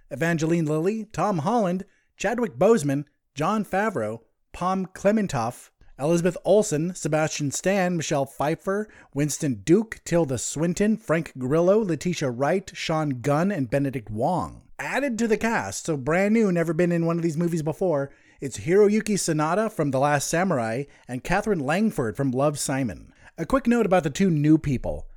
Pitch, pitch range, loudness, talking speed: 165 Hz, 145-195 Hz, -24 LUFS, 155 wpm